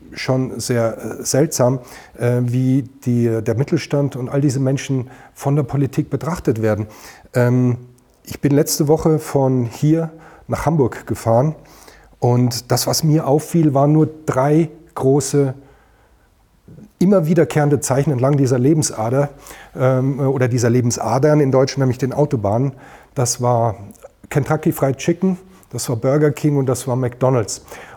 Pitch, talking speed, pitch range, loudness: 135 Hz, 130 wpm, 125-150 Hz, -18 LUFS